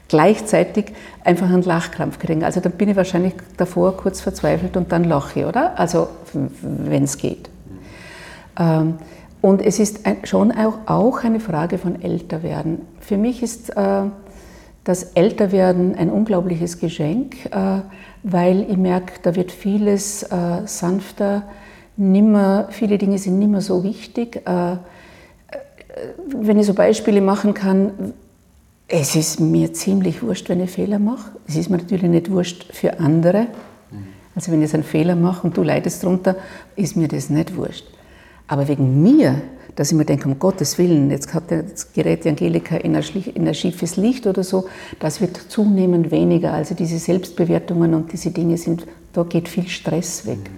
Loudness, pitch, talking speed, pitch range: -19 LUFS, 180 Hz, 155 wpm, 170-200 Hz